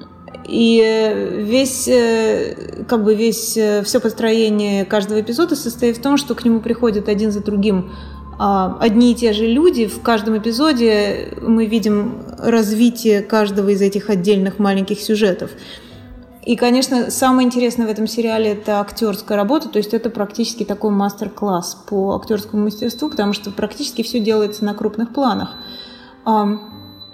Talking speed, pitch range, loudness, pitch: 140 wpm, 205-235 Hz, -17 LUFS, 220 Hz